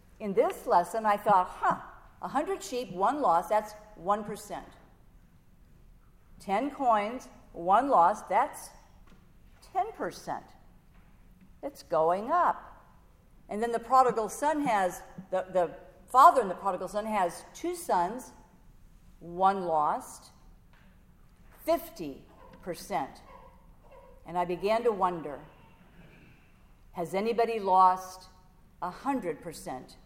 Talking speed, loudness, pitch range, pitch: 100 wpm, -29 LUFS, 180-245 Hz, 205 Hz